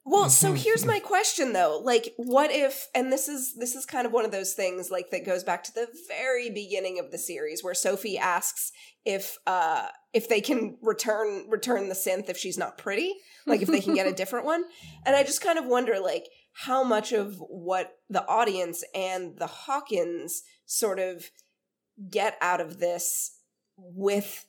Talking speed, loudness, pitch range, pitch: 190 wpm, -27 LUFS, 185-280 Hz, 225 Hz